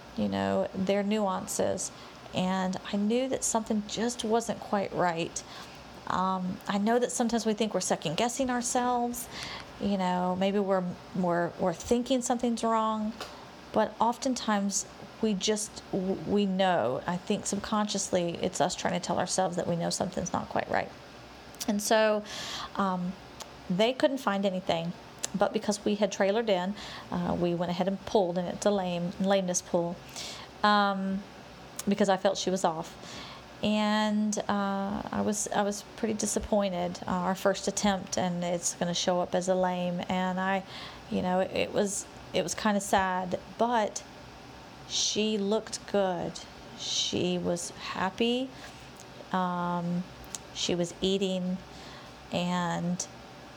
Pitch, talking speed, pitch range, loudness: 195 Hz, 150 wpm, 180-215 Hz, -30 LUFS